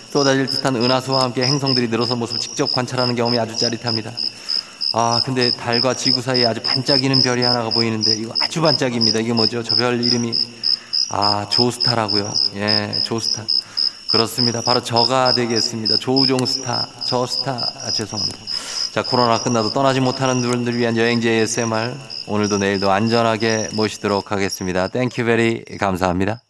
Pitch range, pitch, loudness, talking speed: 110-125 Hz, 115 Hz, -18 LUFS, 385 characters per minute